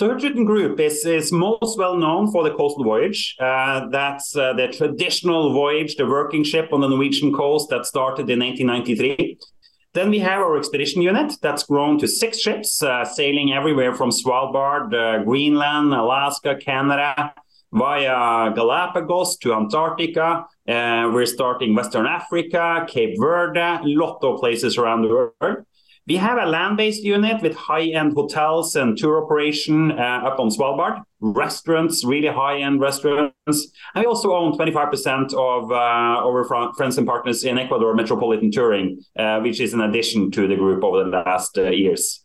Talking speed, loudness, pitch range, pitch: 165 wpm, -19 LUFS, 130-165 Hz, 145 Hz